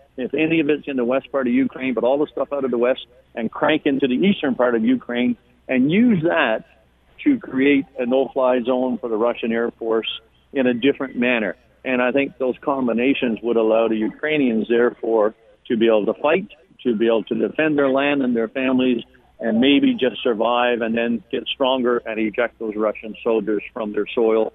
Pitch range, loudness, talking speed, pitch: 115-140 Hz, -20 LUFS, 210 wpm, 125 Hz